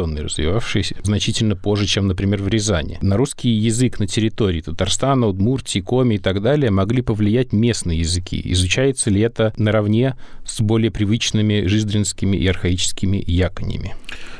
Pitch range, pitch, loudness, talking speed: 95-115 Hz, 105 Hz, -19 LUFS, 140 wpm